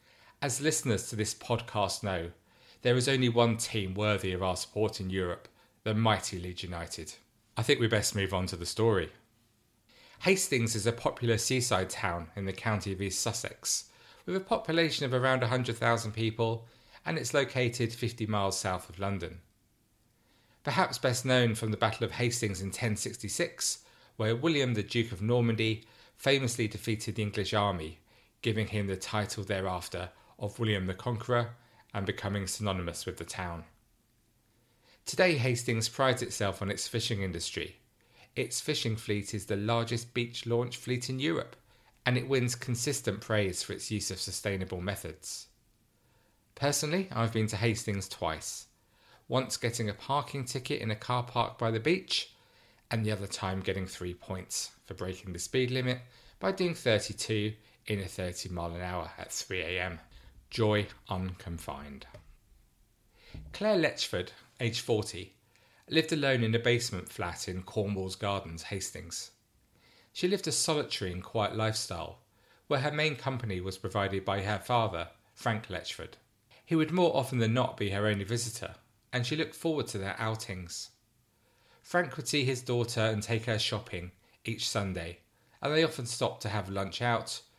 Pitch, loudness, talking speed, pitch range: 110 Hz, -32 LUFS, 160 wpm, 100-120 Hz